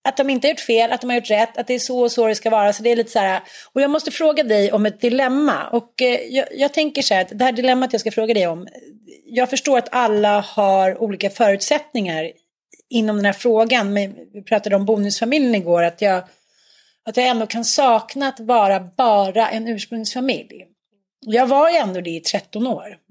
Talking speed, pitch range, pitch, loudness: 225 wpm, 205-255 Hz, 230 Hz, -18 LUFS